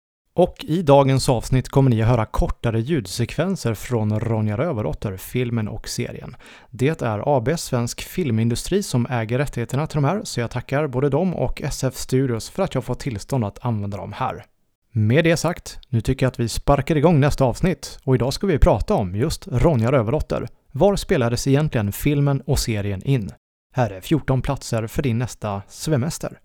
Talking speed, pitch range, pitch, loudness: 180 wpm, 115-145 Hz, 130 Hz, -21 LUFS